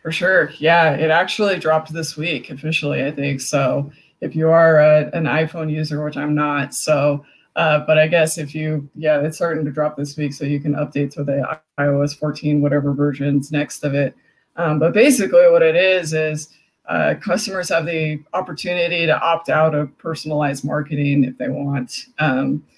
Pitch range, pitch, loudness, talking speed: 145-160 Hz, 150 Hz, -18 LUFS, 185 wpm